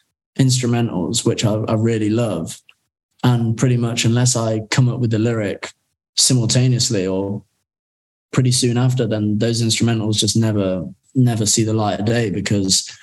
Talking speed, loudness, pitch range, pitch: 150 wpm, -18 LUFS, 105-120 Hz, 115 Hz